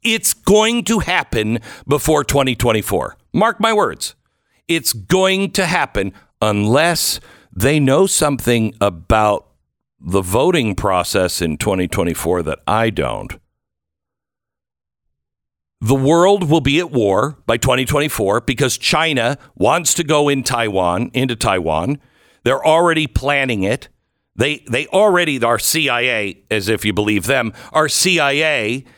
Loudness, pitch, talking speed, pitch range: -16 LUFS, 130 Hz, 120 wpm, 105-155 Hz